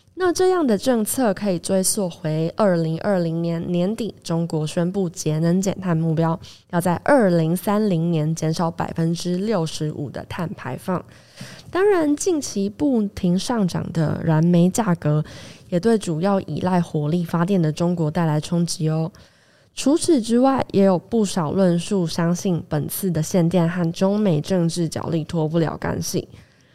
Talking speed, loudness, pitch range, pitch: 240 characters per minute, -21 LUFS, 160-195 Hz, 175 Hz